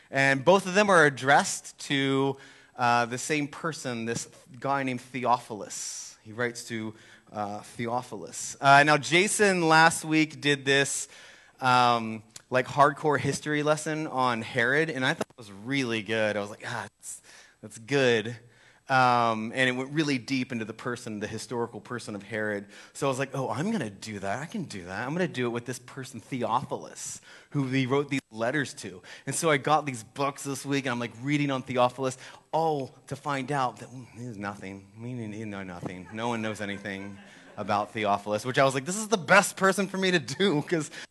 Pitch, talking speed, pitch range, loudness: 130 Hz, 200 wpm, 115-145 Hz, -27 LUFS